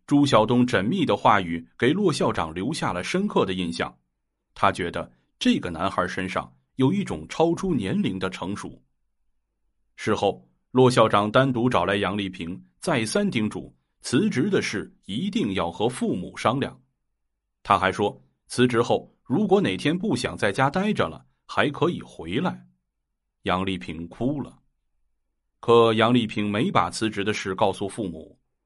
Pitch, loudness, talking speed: 95 Hz, -24 LUFS, 225 characters per minute